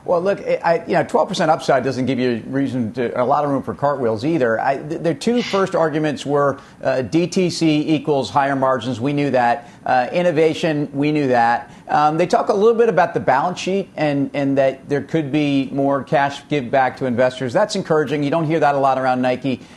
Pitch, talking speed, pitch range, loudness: 140 Hz, 215 wpm, 130-160 Hz, -18 LUFS